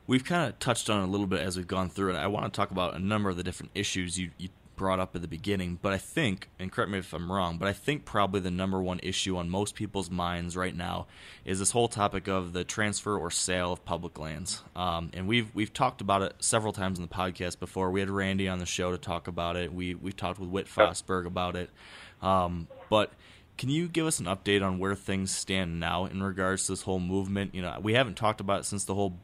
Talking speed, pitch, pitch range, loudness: 260 wpm, 95 Hz, 90-100 Hz, -30 LUFS